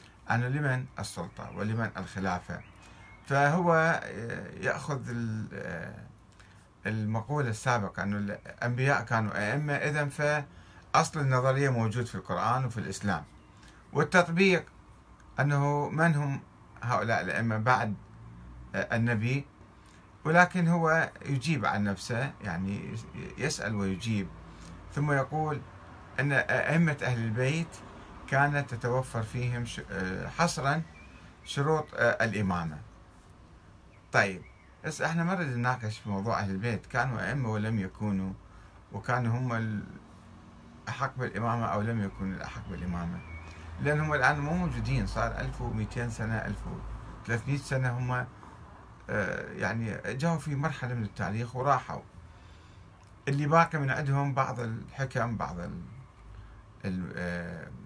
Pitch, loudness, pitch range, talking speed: 115 Hz, -30 LUFS, 100-135 Hz, 105 wpm